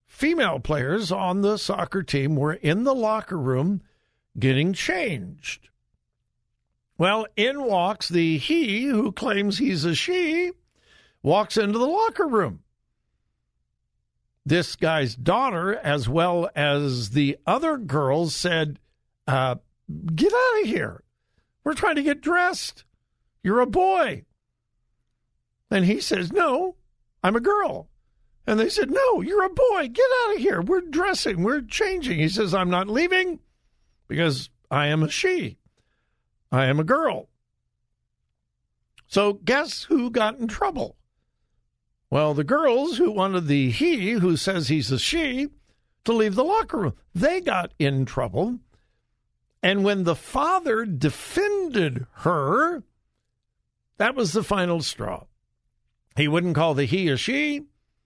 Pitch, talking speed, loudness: 200 Hz, 135 wpm, -23 LUFS